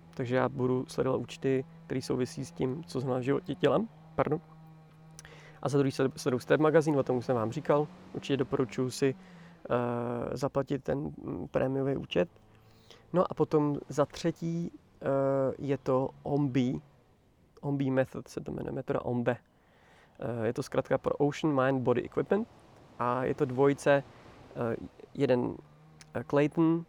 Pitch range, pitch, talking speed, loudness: 125-155 Hz, 140 Hz, 150 wpm, -31 LUFS